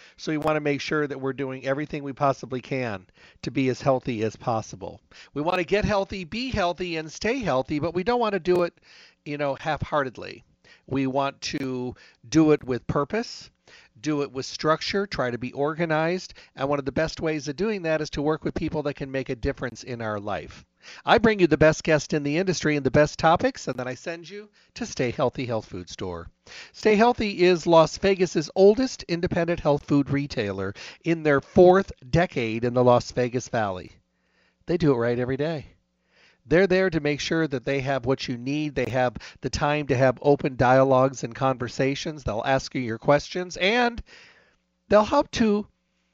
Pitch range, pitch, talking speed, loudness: 130-170 Hz, 145 Hz, 200 wpm, -24 LUFS